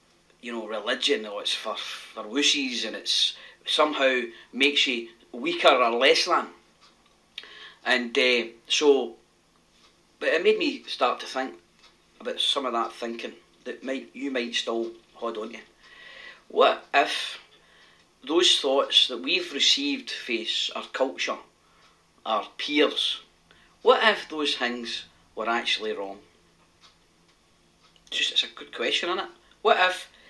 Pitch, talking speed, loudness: 125 Hz, 135 wpm, -24 LUFS